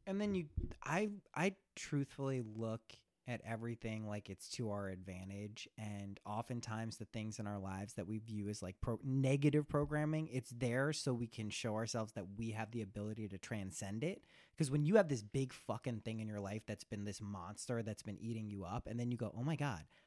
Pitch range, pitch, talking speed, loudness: 105-135 Hz, 115 Hz, 210 wpm, -42 LUFS